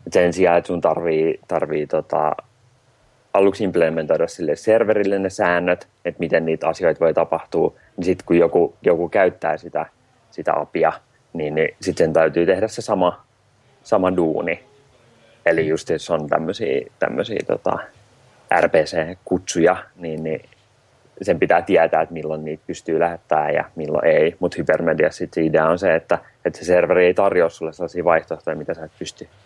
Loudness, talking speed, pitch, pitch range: -20 LUFS, 155 wpm, 90 Hz, 80-115 Hz